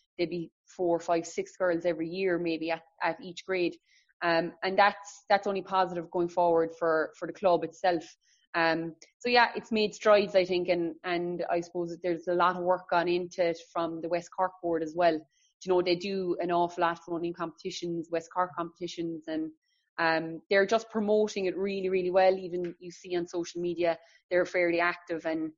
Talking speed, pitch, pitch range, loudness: 205 wpm, 175 Hz, 170-185 Hz, -29 LUFS